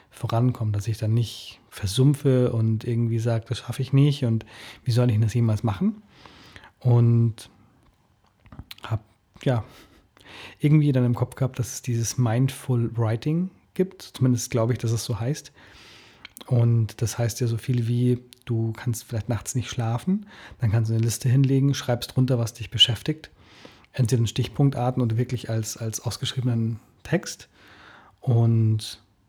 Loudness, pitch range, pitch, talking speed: -24 LUFS, 115-130 Hz, 120 Hz, 155 wpm